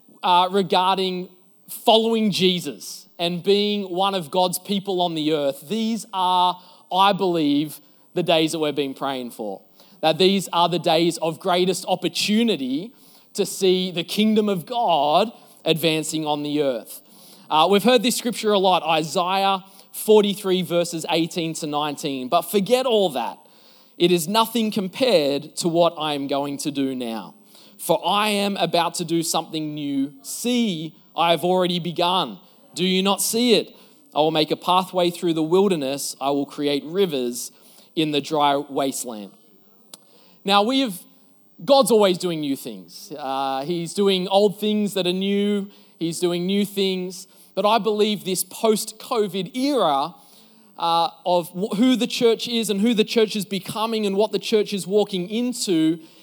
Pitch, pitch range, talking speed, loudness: 185 Hz, 165-210 Hz, 160 wpm, -21 LUFS